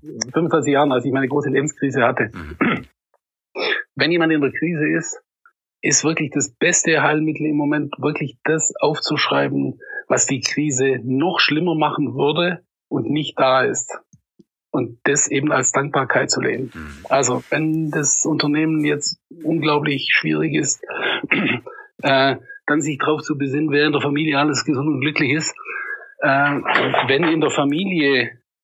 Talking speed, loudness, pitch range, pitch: 150 wpm, -19 LUFS, 140-155 Hz, 150 Hz